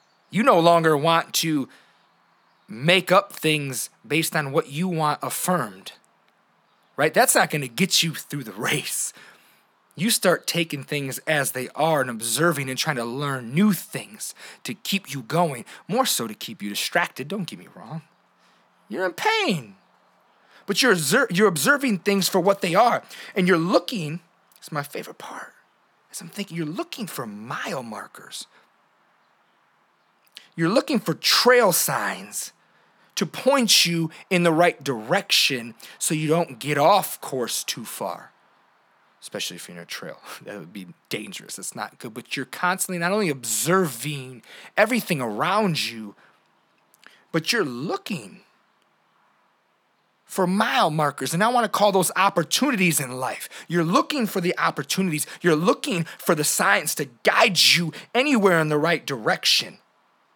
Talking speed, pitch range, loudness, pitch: 155 wpm, 145-195 Hz, -22 LUFS, 170 Hz